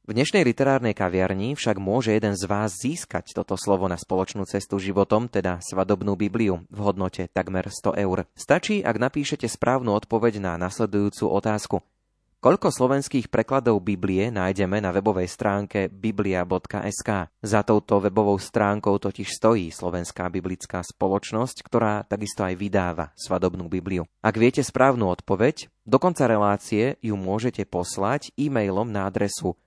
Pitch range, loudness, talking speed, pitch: 95-110 Hz, -24 LUFS, 140 wpm, 100 Hz